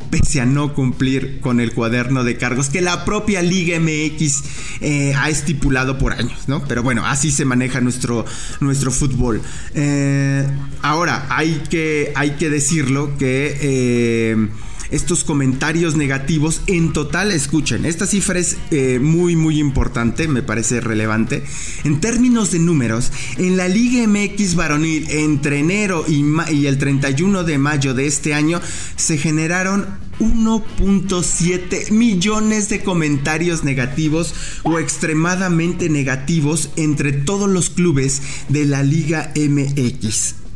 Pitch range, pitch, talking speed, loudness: 135-170 Hz, 150 Hz, 135 wpm, -17 LUFS